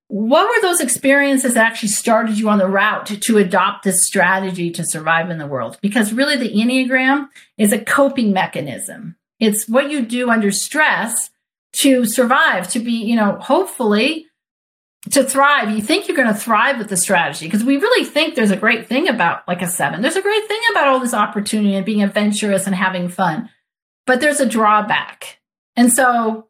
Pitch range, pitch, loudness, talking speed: 200-270 Hz, 225 Hz, -16 LUFS, 190 wpm